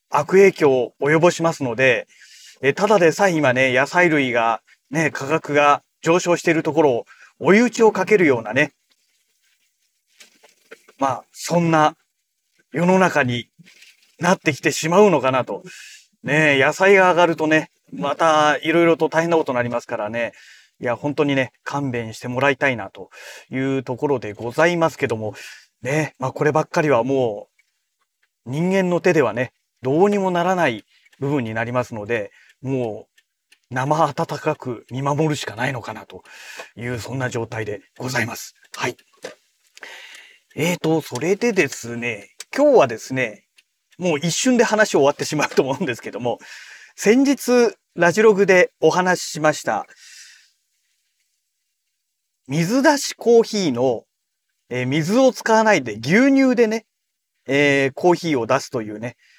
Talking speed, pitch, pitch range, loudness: 285 characters per minute, 155 Hz, 130-180 Hz, -19 LUFS